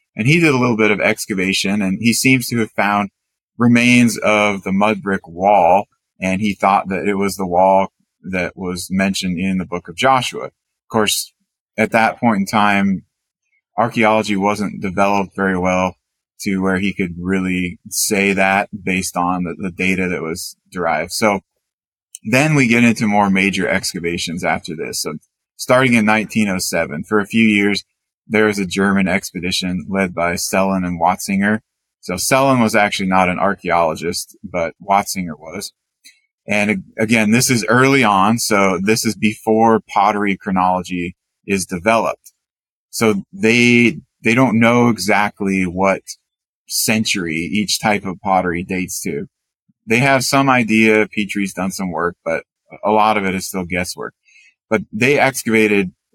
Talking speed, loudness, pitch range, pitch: 160 wpm, -16 LUFS, 95-110 Hz, 100 Hz